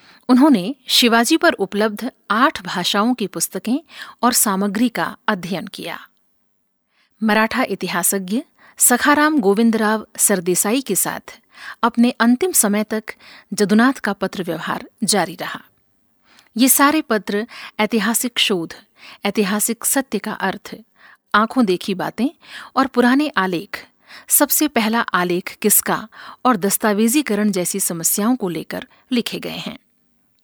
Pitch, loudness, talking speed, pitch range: 220 Hz, -17 LUFS, 115 wpm, 200-250 Hz